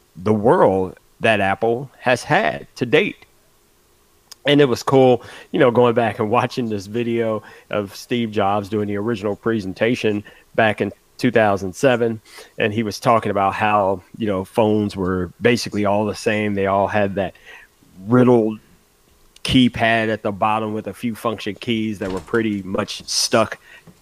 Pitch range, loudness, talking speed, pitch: 100-115 Hz, -19 LUFS, 155 wpm, 110 Hz